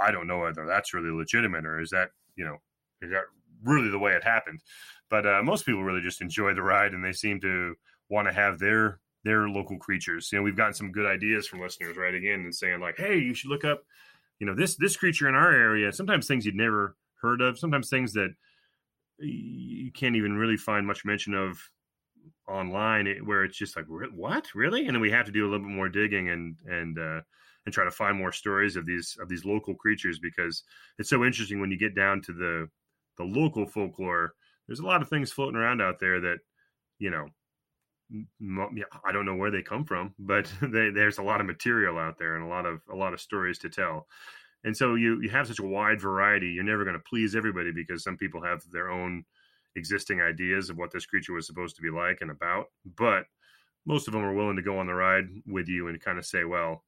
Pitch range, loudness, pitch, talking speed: 90-110 Hz, -28 LUFS, 100 Hz, 230 wpm